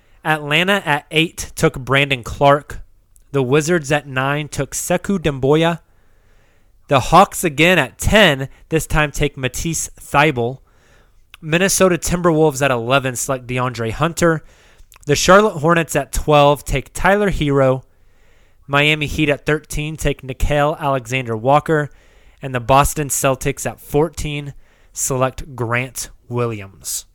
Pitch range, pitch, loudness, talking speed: 125-155 Hz, 140 Hz, -17 LUFS, 120 wpm